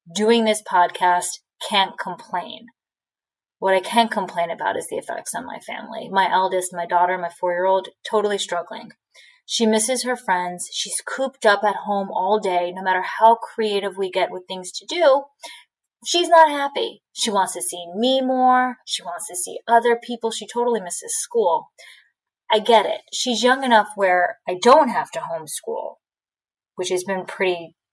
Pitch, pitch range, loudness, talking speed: 215 Hz, 185-245 Hz, -20 LUFS, 175 wpm